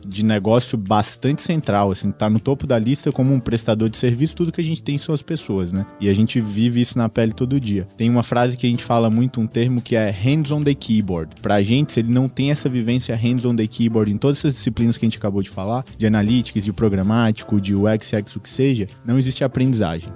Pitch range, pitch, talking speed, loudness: 110-130 Hz, 115 Hz, 250 wpm, -19 LUFS